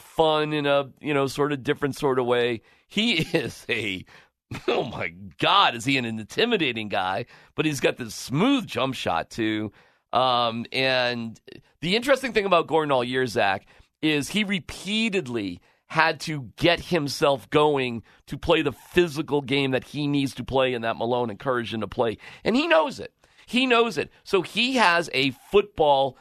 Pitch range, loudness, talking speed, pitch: 120-165 Hz, -24 LUFS, 175 wpm, 140 Hz